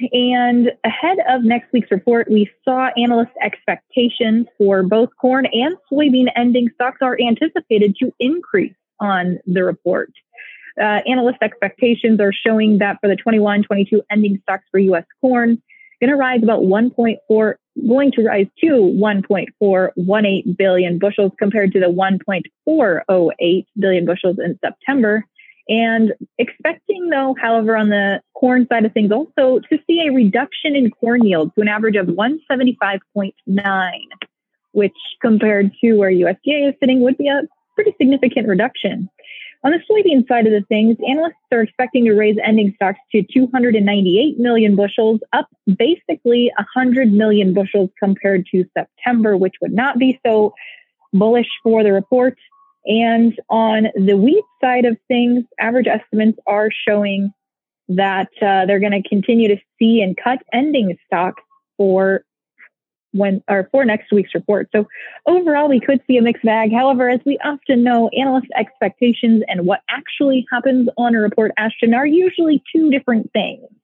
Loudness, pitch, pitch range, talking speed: -16 LUFS, 230 Hz, 205-255 Hz, 155 wpm